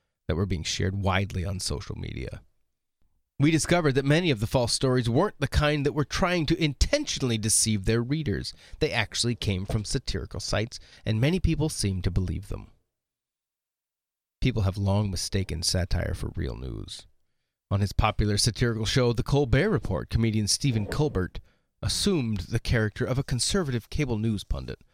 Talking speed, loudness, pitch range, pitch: 165 wpm, -27 LUFS, 100-140 Hz, 115 Hz